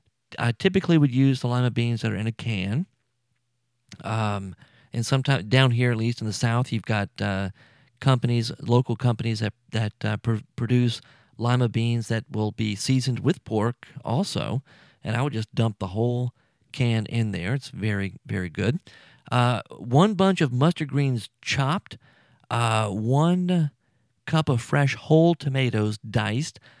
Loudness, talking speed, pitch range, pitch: -25 LUFS, 160 wpm, 110-135 Hz, 120 Hz